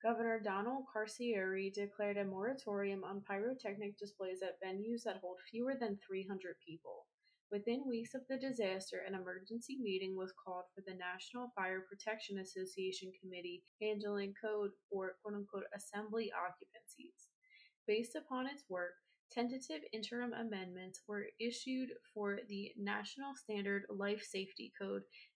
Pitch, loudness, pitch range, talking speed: 205 Hz, -44 LUFS, 190-230 Hz, 135 wpm